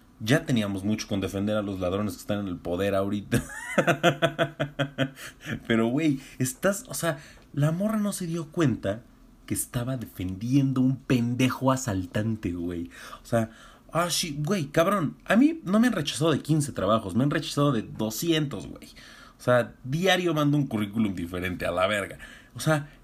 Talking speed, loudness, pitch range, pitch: 170 wpm, -27 LUFS, 110-155 Hz, 130 Hz